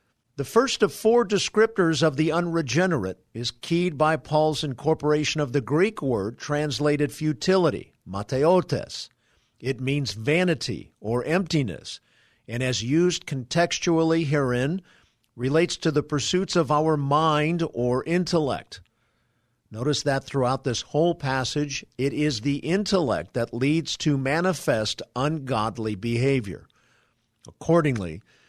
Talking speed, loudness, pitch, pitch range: 120 wpm, -24 LUFS, 145 Hz, 125-165 Hz